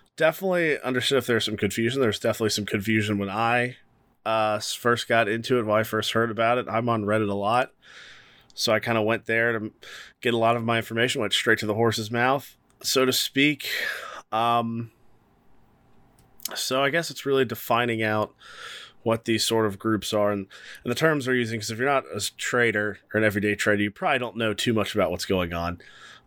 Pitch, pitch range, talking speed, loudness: 115 Hz, 110-125 Hz, 205 wpm, -24 LUFS